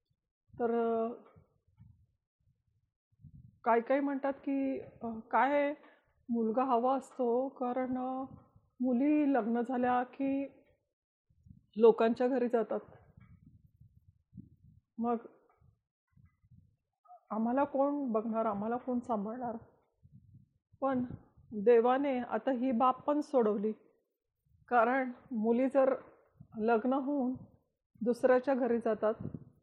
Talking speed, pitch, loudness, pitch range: 80 wpm, 250 Hz, -32 LUFS, 235-270 Hz